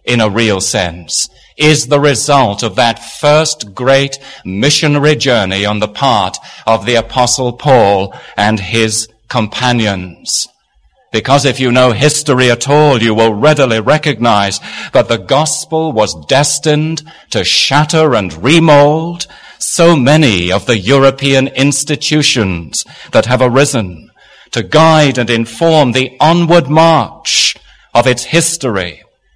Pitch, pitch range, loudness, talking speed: 130 Hz, 110-150 Hz, -10 LUFS, 125 wpm